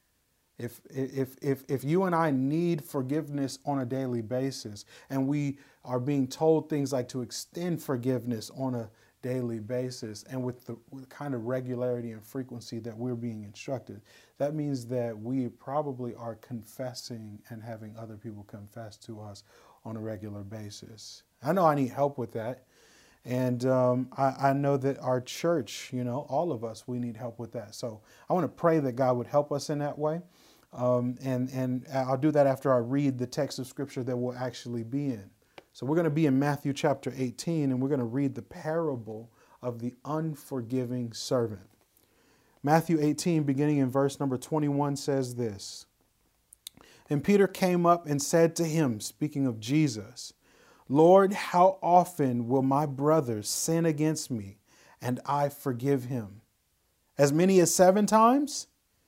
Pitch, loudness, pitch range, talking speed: 130 Hz, -29 LUFS, 120-145 Hz, 175 wpm